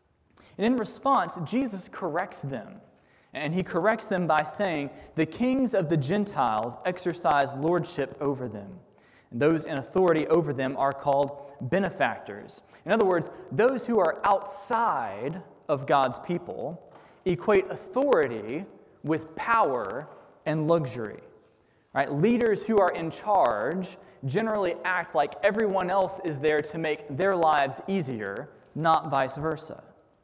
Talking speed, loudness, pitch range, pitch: 130 wpm, -27 LUFS, 150-200 Hz, 175 Hz